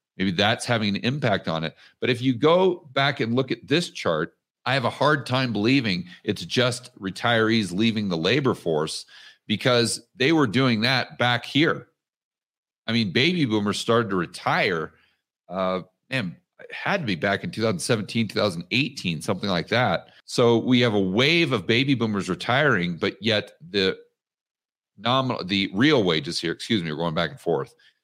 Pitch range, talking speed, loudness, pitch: 100-130 Hz, 175 wpm, -23 LUFS, 120 Hz